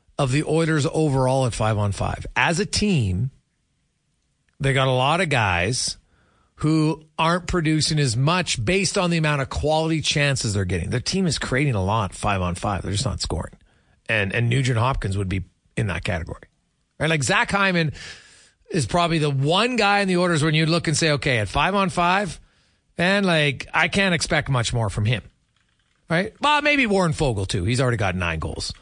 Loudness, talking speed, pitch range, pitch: -21 LUFS, 200 wpm, 110-165 Hz, 140 Hz